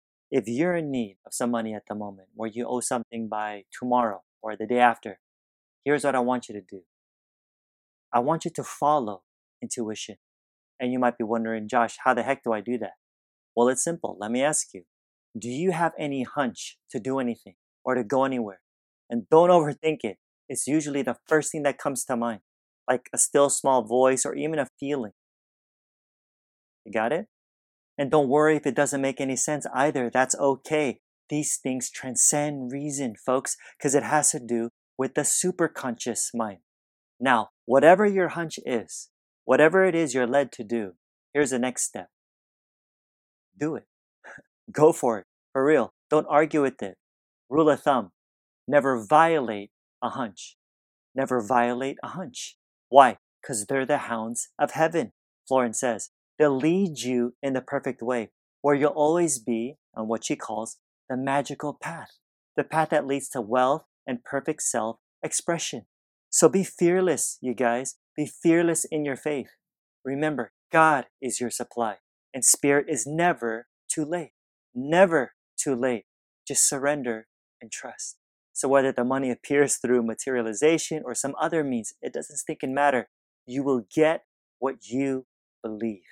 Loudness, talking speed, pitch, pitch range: -25 LUFS, 170 wpm, 130 Hz, 115-145 Hz